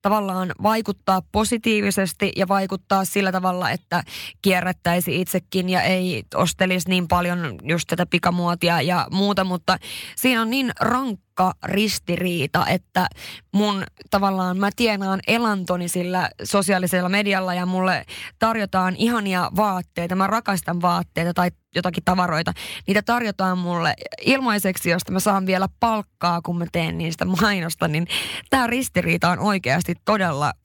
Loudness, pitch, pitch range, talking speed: -21 LUFS, 185 Hz, 175-200 Hz, 130 wpm